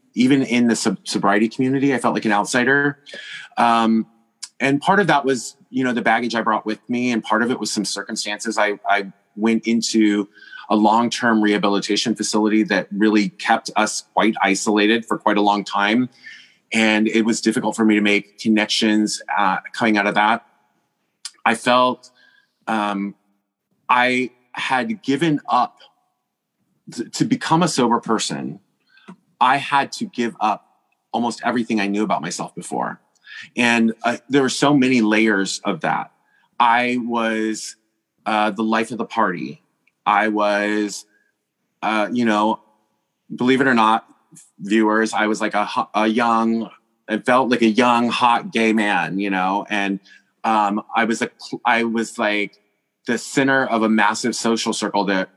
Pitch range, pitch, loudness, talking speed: 105-120 Hz, 110 Hz, -19 LUFS, 160 wpm